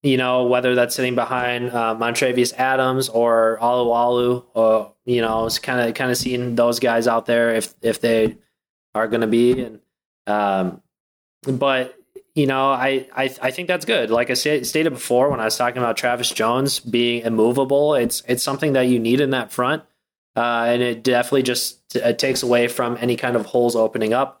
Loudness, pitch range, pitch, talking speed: -19 LUFS, 115-130 Hz, 120 Hz, 195 wpm